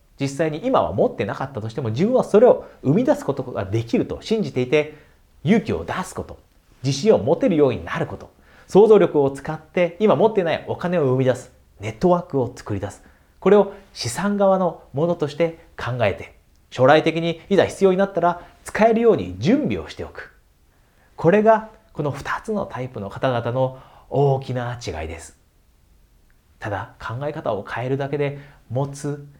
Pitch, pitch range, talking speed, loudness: 140 Hz, 120-175 Hz, 340 characters per minute, -21 LUFS